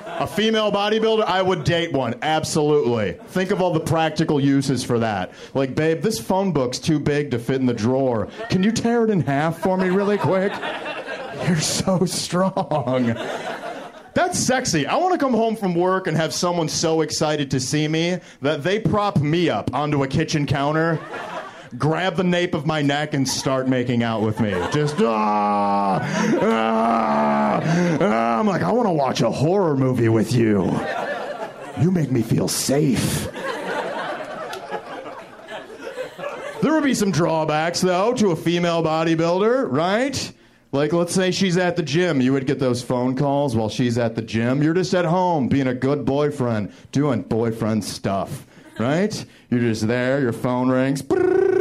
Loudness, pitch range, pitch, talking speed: -21 LUFS, 125-180 Hz, 155 Hz, 170 wpm